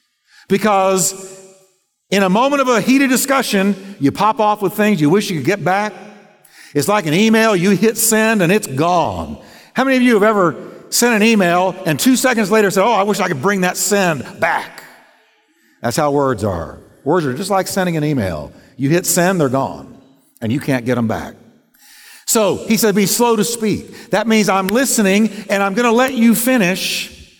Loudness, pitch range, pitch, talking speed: -15 LUFS, 175-220 Hz, 195 Hz, 200 wpm